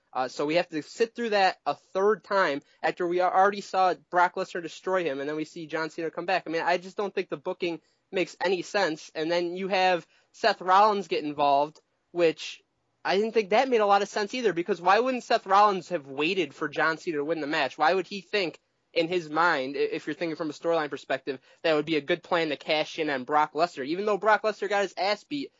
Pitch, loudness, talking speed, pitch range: 175 Hz, -27 LUFS, 250 wpm, 155-200 Hz